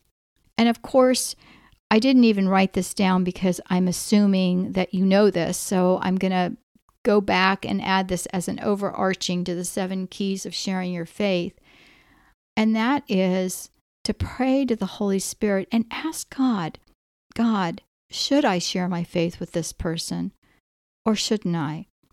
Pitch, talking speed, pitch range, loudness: 190 Hz, 165 wpm, 180-220 Hz, -23 LUFS